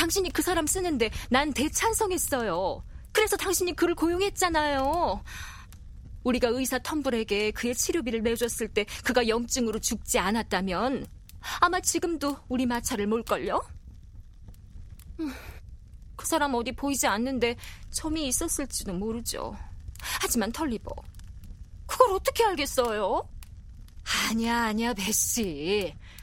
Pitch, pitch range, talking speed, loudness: 250 Hz, 220-320 Hz, 270 characters per minute, -27 LUFS